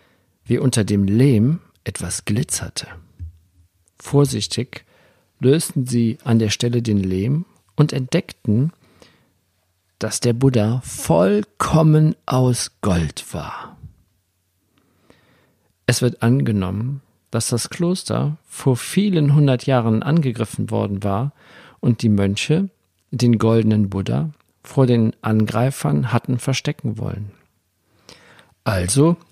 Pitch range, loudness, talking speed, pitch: 100-135 Hz, -19 LUFS, 100 wpm, 115 Hz